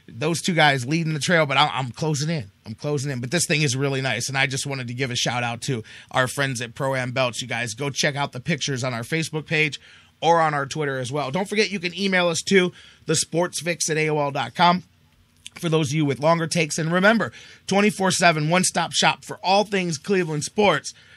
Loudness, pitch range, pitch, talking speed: -22 LUFS, 135-170 Hz, 155 Hz, 230 wpm